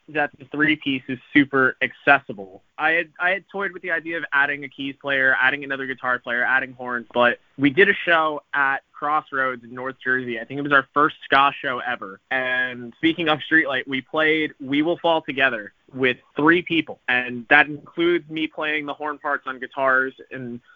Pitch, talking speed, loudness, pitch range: 140 Hz, 200 wpm, -21 LUFS, 130-155 Hz